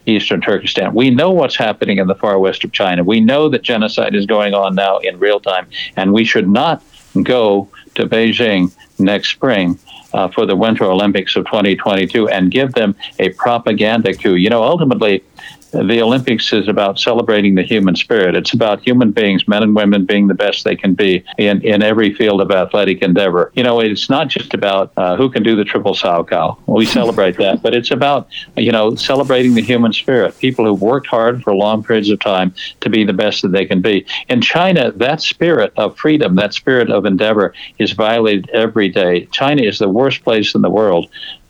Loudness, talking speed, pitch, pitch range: -13 LUFS, 205 wpm, 105 Hz, 100-115 Hz